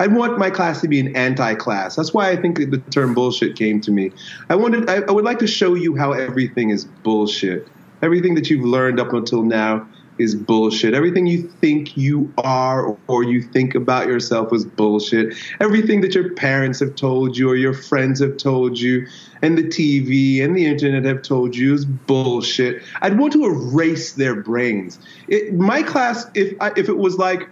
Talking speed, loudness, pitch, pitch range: 205 wpm, -18 LUFS, 135 Hz, 125-175 Hz